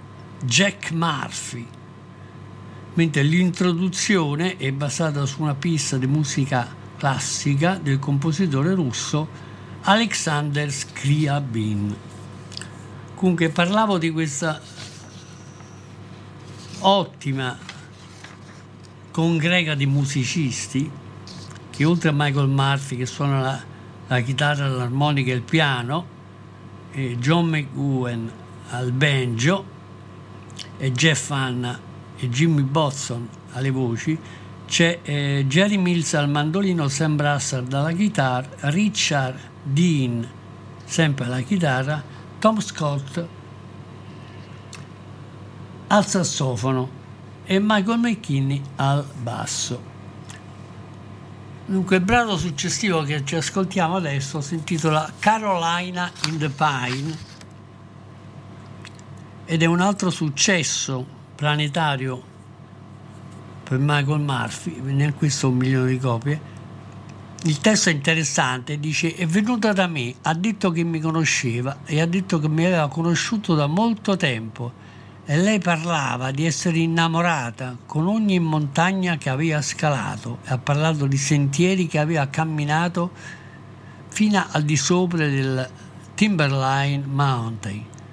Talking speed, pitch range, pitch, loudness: 105 wpm, 125-165 Hz, 140 Hz, -22 LUFS